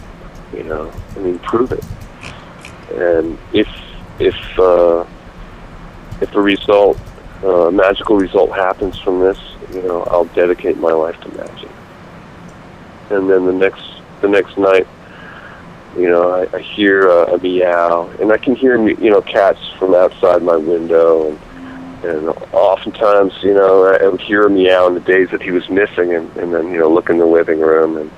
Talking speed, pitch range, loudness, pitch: 175 wpm, 85-95 Hz, -13 LUFS, 90 Hz